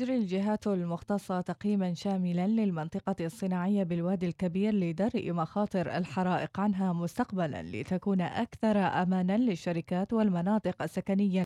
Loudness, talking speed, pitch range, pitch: -31 LUFS, 105 wpm, 175-205 Hz, 185 Hz